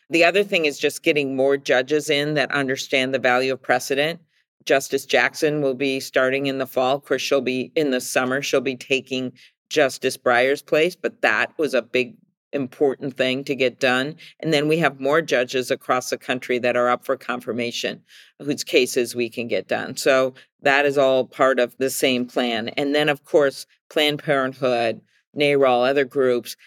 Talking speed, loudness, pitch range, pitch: 190 wpm, -21 LUFS, 125-145 Hz, 135 Hz